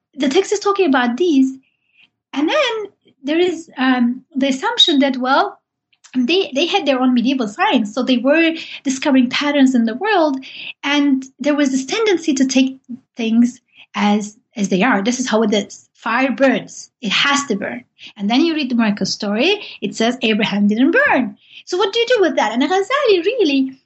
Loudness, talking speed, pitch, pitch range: -16 LUFS, 190 wpm, 270 Hz, 245-320 Hz